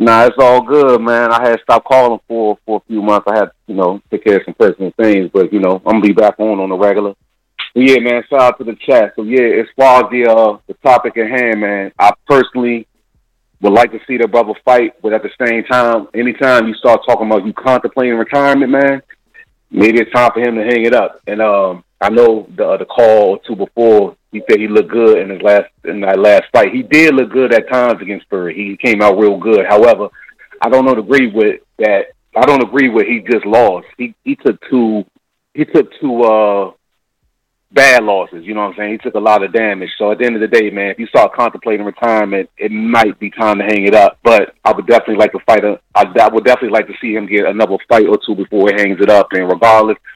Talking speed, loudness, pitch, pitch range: 250 wpm, -11 LUFS, 110 Hz, 105-125 Hz